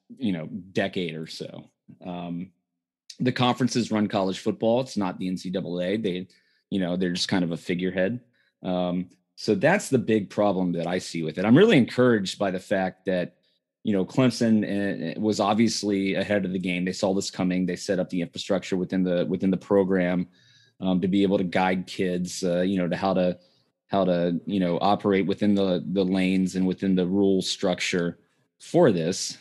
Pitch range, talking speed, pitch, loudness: 90-100 Hz, 190 wpm, 95 Hz, -25 LUFS